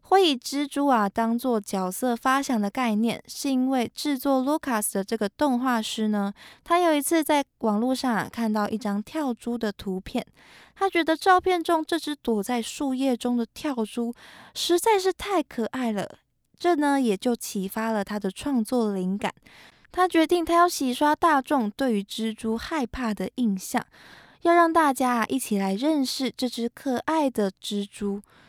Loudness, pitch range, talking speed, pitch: -25 LUFS, 220-295 Hz, 255 characters per minute, 250 Hz